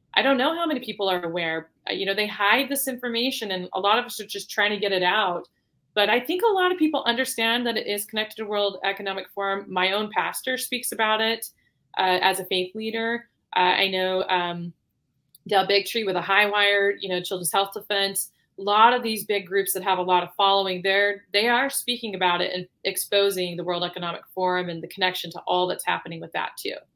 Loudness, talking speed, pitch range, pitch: -23 LUFS, 225 wpm, 185-220 Hz, 200 Hz